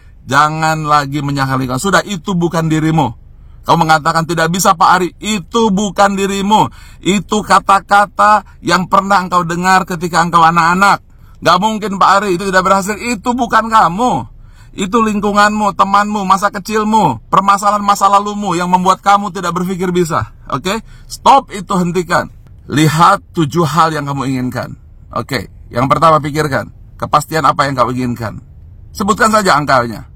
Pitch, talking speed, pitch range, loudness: 180 Hz, 145 wpm, 150-200 Hz, -12 LUFS